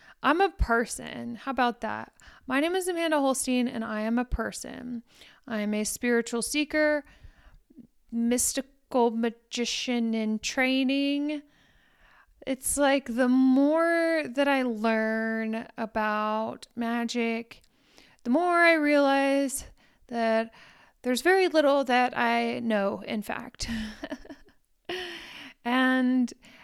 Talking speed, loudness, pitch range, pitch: 110 wpm, -27 LUFS, 230-285 Hz, 250 Hz